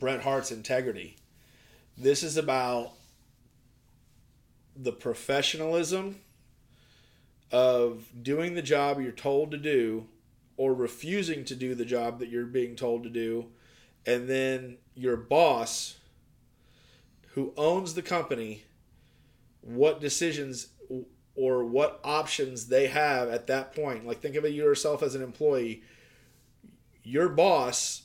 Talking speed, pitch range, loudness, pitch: 120 wpm, 120-145 Hz, -29 LUFS, 130 Hz